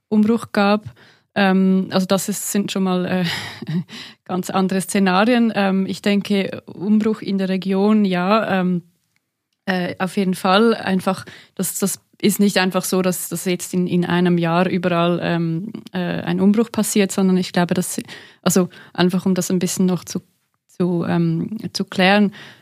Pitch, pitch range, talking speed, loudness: 190 Hz, 180-200 Hz, 165 wpm, -19 LUFS